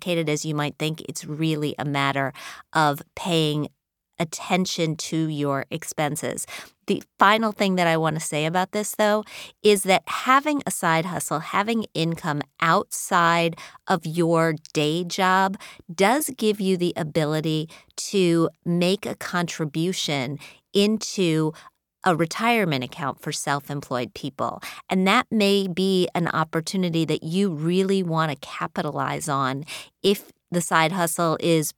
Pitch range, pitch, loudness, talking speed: 155-190 Hz, 170 Hz, -23 LUFS, 140 wpm